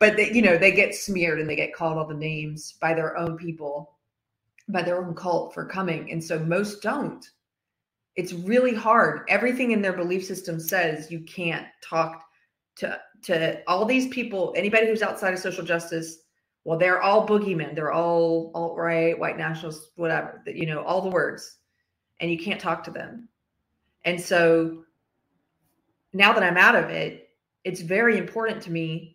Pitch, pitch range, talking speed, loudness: 170 Hz, 160-190 Hz, 180 wpm, -24 LUFS